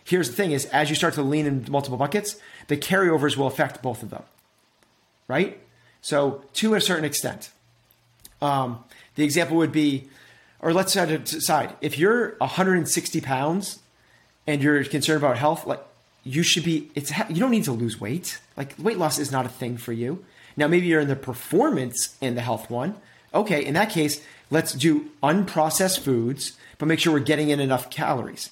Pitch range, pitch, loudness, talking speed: 130-165 Hz, 150 Hz, -23 LUFS, 185 wpm